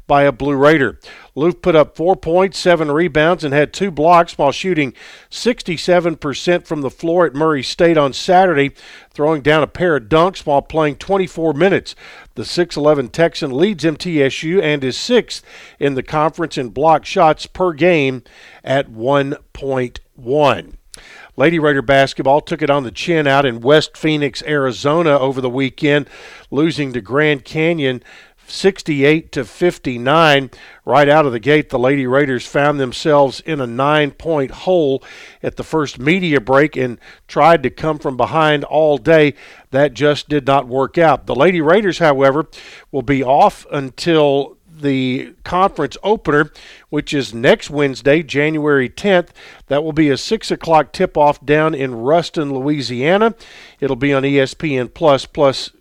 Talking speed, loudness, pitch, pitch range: 155 wpm, -15 LUFS, 150 Hz, 135-165 Hz